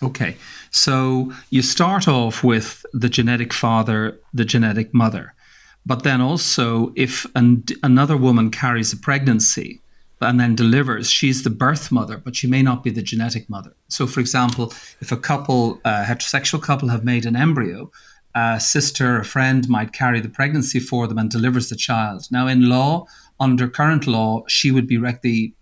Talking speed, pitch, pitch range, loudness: 180 wpm, 125 Hz, 115-130 Hz, -18 LUFS